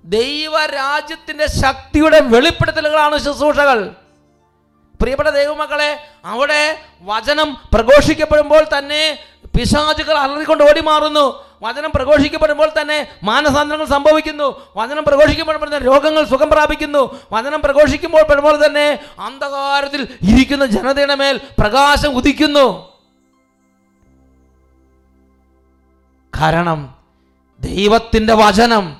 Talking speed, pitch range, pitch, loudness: 80 wpm, 210-300 Hz, 285 Hz, -13 LUFS